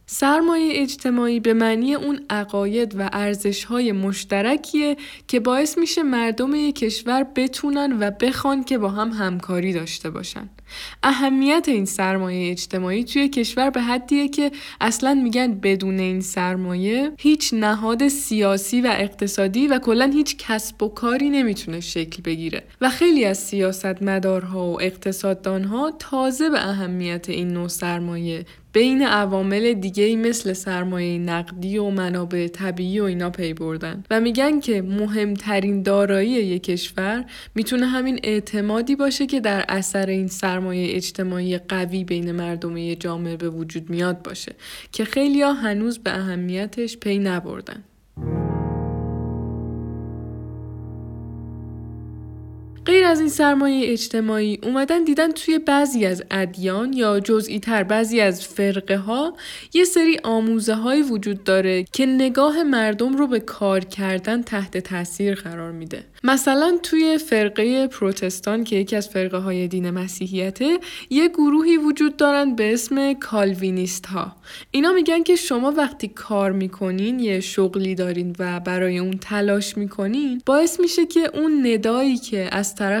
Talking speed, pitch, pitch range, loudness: 135 wpm, 210 Hz, 185-265 Hz, -21 LUFS